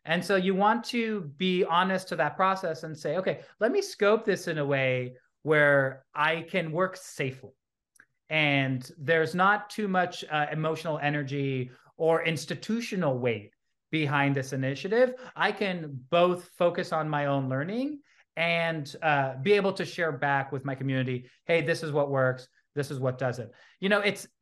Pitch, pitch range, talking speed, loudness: 160 Hz, 135-185 Hz, 170 wpm, -28 LUFS